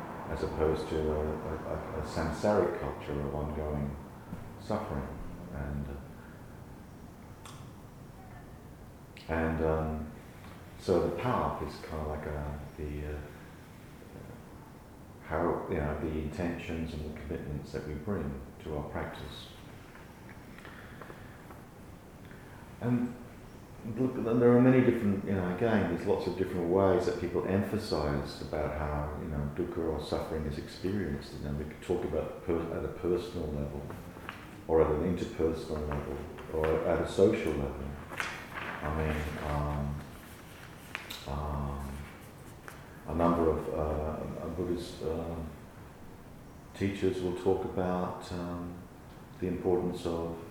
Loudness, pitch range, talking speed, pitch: -33 LUFS, 75-90 Hz, 125 wpm, 80 Hz